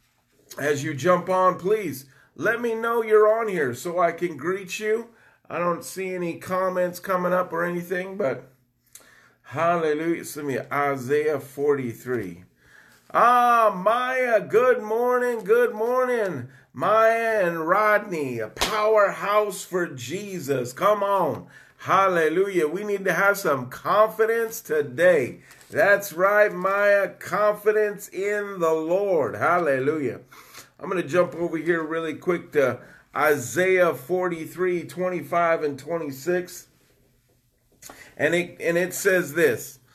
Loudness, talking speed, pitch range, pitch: -23 LUFS, 125 wpm, 155-210 Hz, 180 Hz